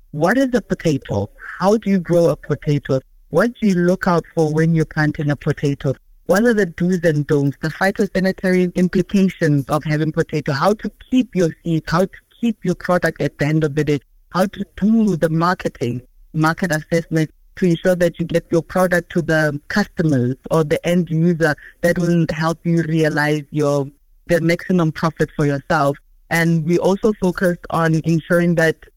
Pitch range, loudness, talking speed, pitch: 155-185 Hz, -18 LUFS, 180 wpm, 165 Hz